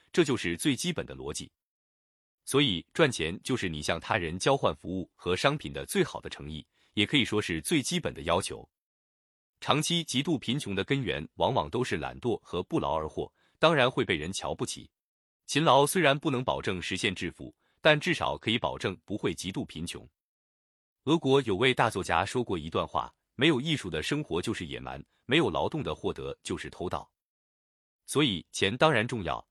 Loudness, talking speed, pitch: -29 LUFS, 280 characters per minute, 115 Hz